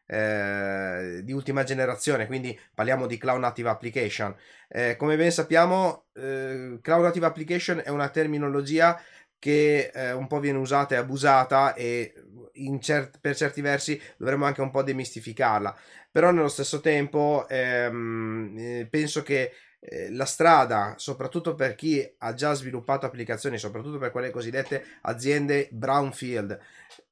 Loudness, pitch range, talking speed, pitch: -26 LUFS, 120-145 Hz, 135 wpm, 135 Hz